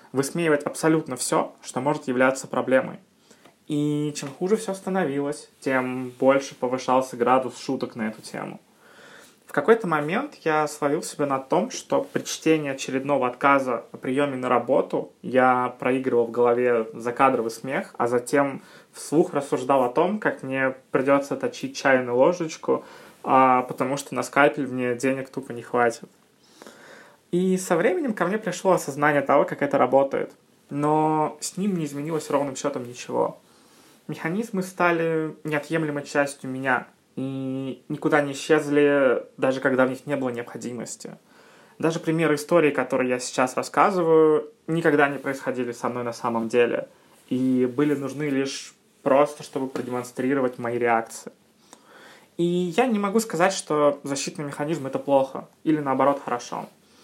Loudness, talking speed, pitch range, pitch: -24 LUFS, 145 wpm, 130-155 Hz, 140 Hz